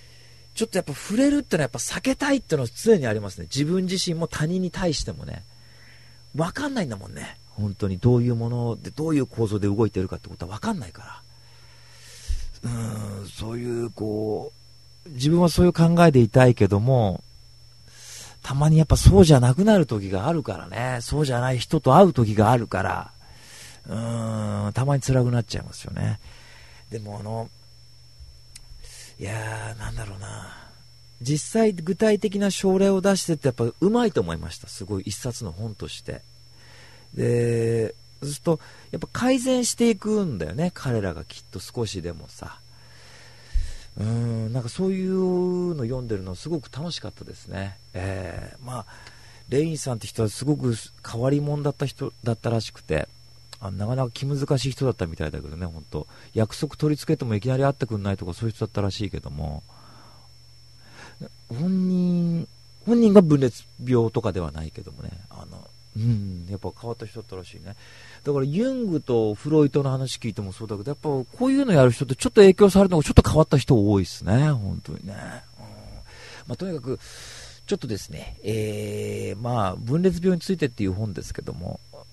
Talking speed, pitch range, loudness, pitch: 365 characters per minute, 95-150 Hz, -23 LUFS, 115 Hz